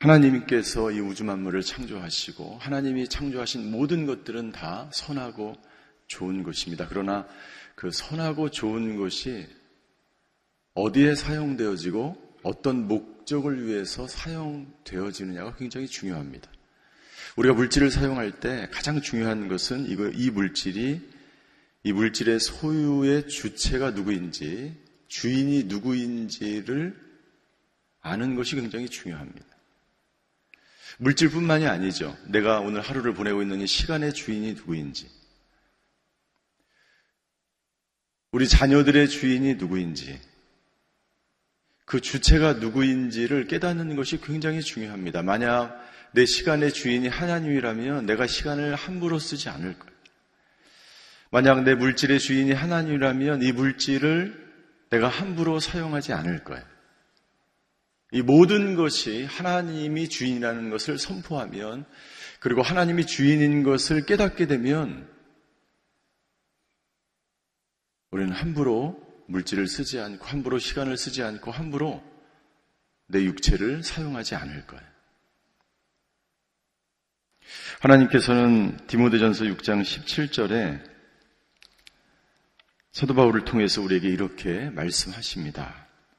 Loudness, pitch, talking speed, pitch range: -25 LUFS, 130 Hz, 265 characters per minute, 105-145 Hz